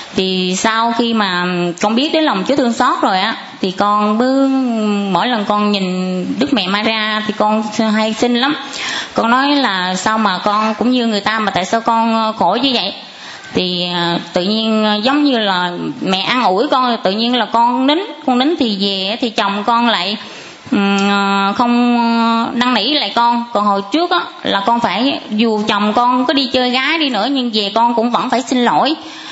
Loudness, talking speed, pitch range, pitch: -14 LUFS, 200 wpm, 205-255 Hz, 230 Hz